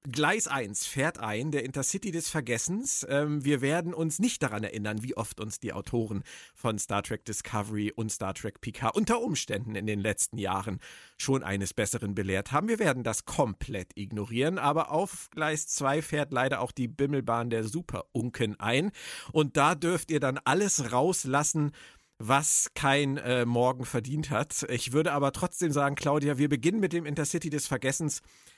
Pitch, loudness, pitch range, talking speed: 135 Hz, -29 LUFS, 115-155 Hz, 170 wpm